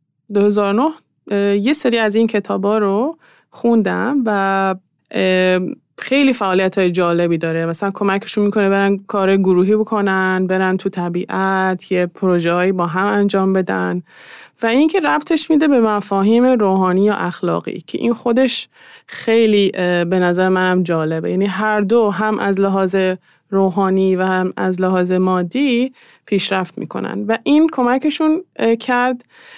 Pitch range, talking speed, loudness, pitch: 185-230 Hz, 135 wpm, -16 LUFS, 195 Hz